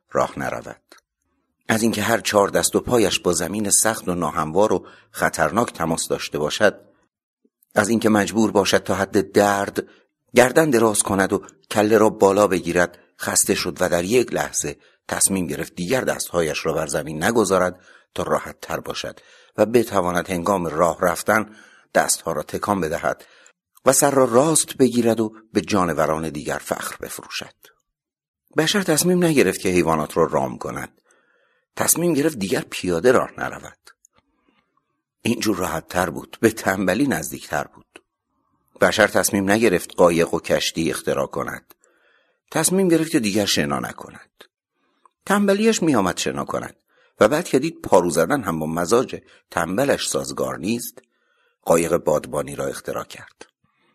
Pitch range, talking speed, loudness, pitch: 90-125 Hz, 145 wpm, -20 LUFS, 105 Hz